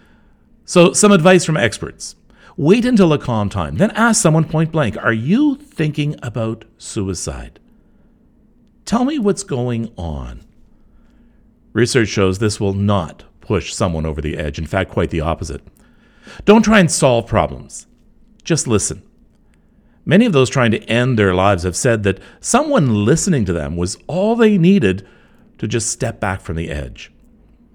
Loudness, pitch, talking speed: -16 LUFS, 115 Hz, 160 wpm